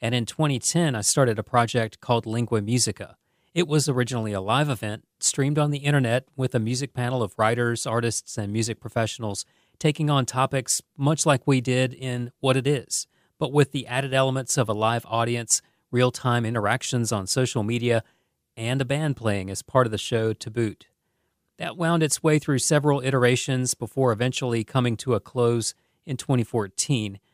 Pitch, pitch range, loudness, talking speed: 125 Hz, 115-135 Hz, -24 LUFS, 180 wpm